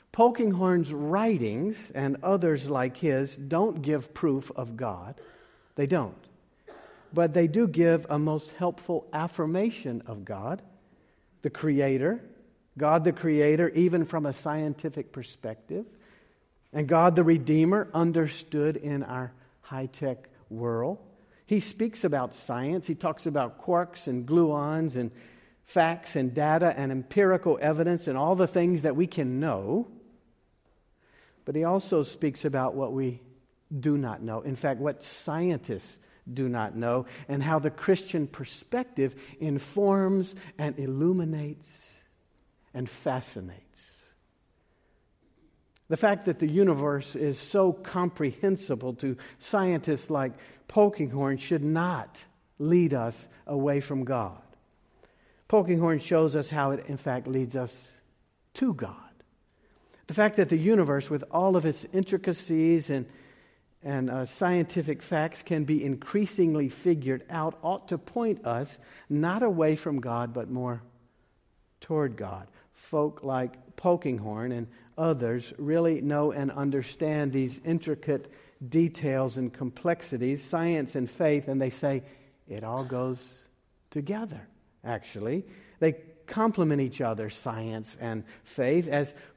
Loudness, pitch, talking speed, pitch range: -28 LUFS, 150 Hz, 130 wpm, 130-170 Hz